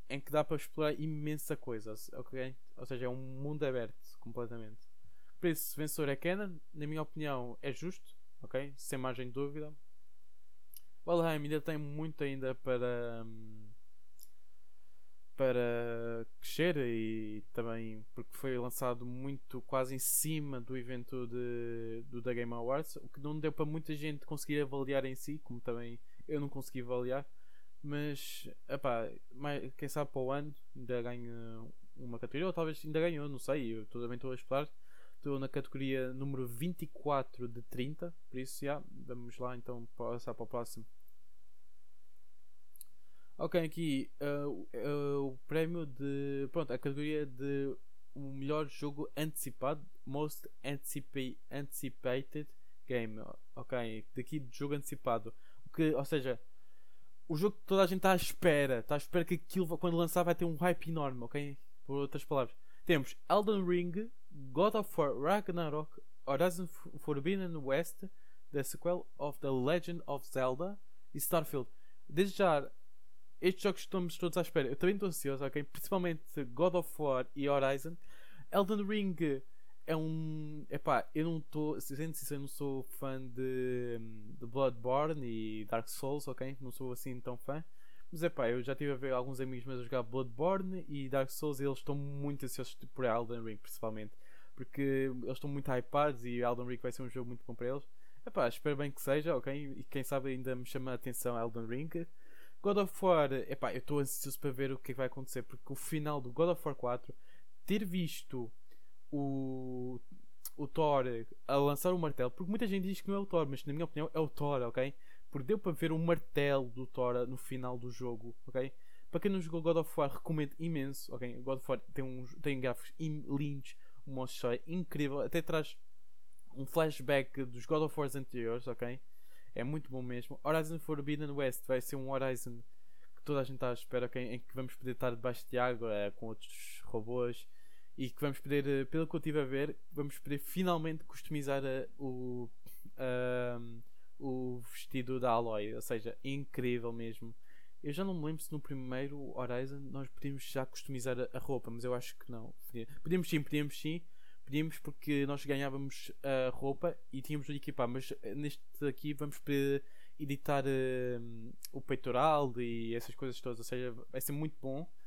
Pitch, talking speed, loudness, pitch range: 140 Hz, 180 wpm, -38 LUFS, 125-155 Hz